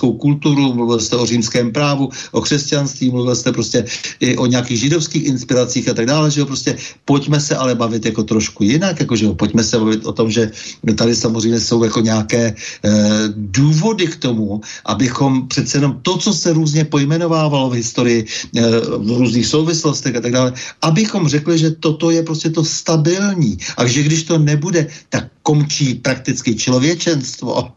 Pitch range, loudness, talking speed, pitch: 120-155 Hz, -15 LUFS, 175 wpm, 130 Hz